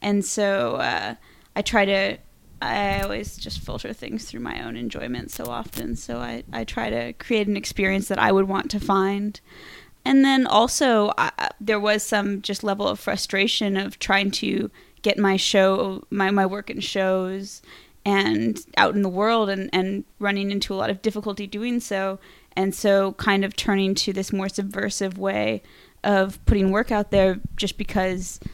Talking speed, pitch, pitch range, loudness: 180 wpm, 195 Hz, 195-210 Hz, -23 LUFS